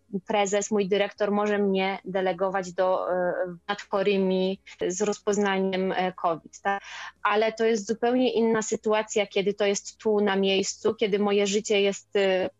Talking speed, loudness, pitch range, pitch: 130 wpm, -26 LUFS, 190-210 Hz, 200 Hz